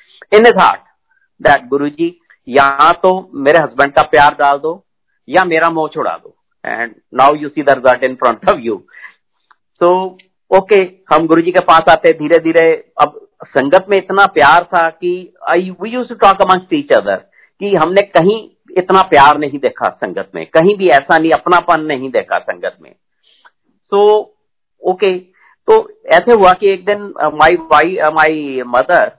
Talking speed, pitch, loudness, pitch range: 170 wpm, 175 Hz, -11 LUFS, 155-200 Hz